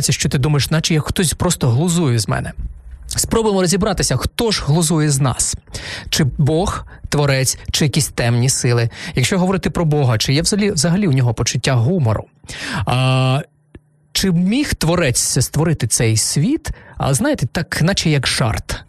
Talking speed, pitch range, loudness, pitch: 155 wpm, 120-165 Hz, -16 LUFS, 140 Hz